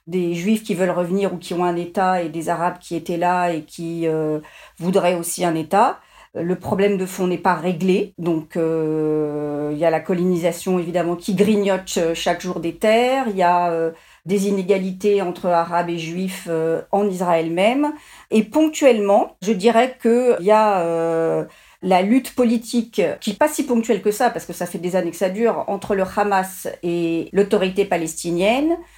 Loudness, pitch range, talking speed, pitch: -20 LUFS, 170-205 Hz, 190 wpm, 185 Hz